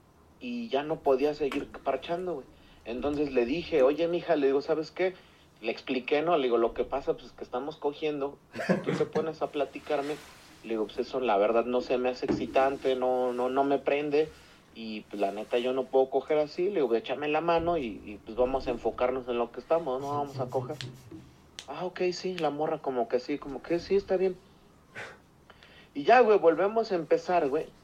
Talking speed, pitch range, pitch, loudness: 215 wpm, 125-165 Hz, 145 Hz, -29 LUFS